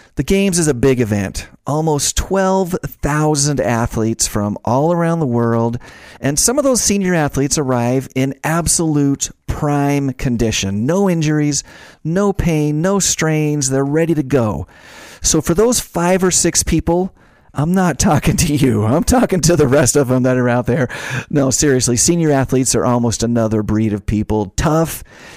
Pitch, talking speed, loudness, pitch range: 145 Hz, 165 wpm, -15 LUFS, 120-165 Hz